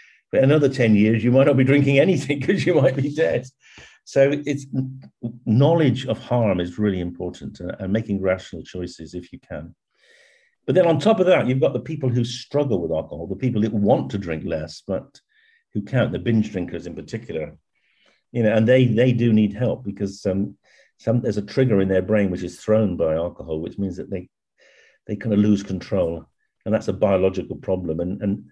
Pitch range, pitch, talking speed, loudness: 95-135 Hz, 110 Hz, 205 wpm, -21 LUFS